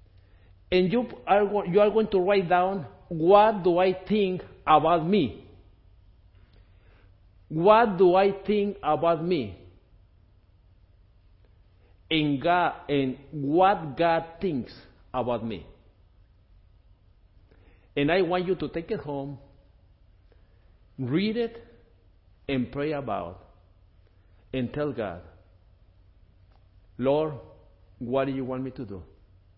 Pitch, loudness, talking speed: 110 Hz, -25 LUFS, 110 wpm